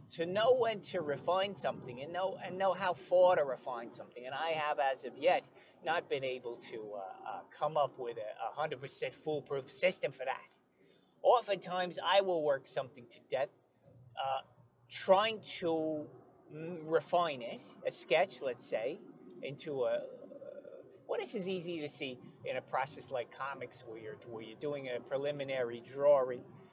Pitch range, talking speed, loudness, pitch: 135-195 Hz, 170 wpm, -36 LUFS, 165 Hz